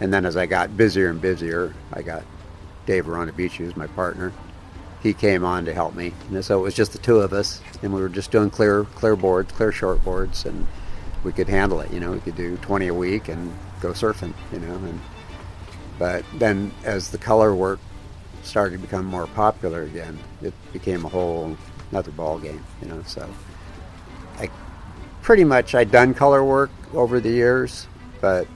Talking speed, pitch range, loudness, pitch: 195 wpm, 85-100 Hz, -22 LUFS, 95 Hz